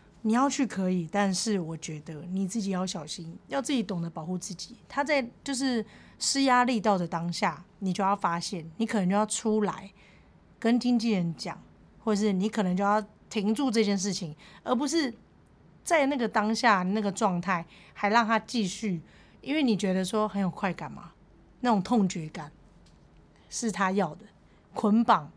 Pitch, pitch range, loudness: 205 Hz, 185-225 Hz, -28 LUFS